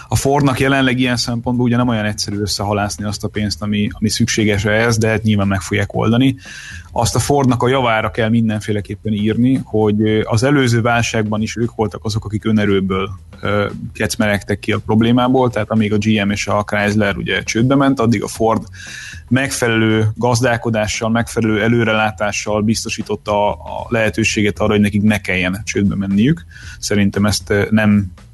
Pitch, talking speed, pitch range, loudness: 110 Hz, 160 wpm, 105-115 Hz, -16 LUFS